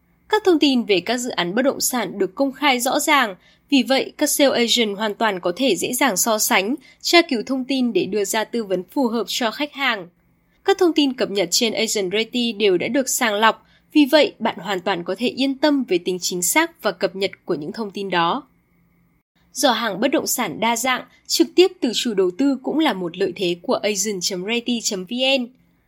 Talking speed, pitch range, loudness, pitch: 220 wpm, 200-275 Hz, -20 LUFS, 235 Hz